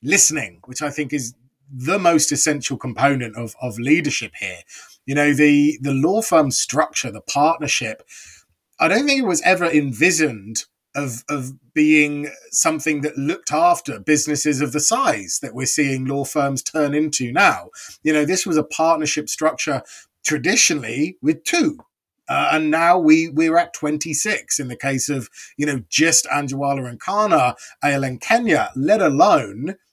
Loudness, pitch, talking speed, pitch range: -18 LUFS, 150 Hz, 160 wpm, 135-160 Hz